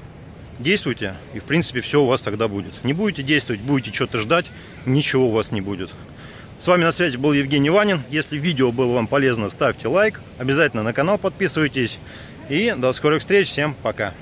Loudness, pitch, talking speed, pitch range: -20 LUFS, 135 Hz, 185 wpm, 115-155 Hz